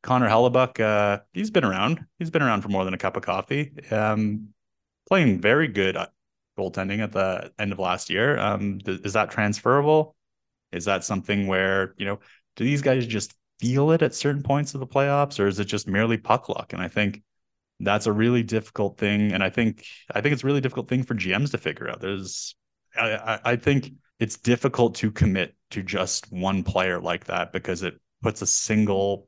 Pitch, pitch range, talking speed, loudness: 105 Hz, 95-125 Hz, 205 wpm, -24 LUFS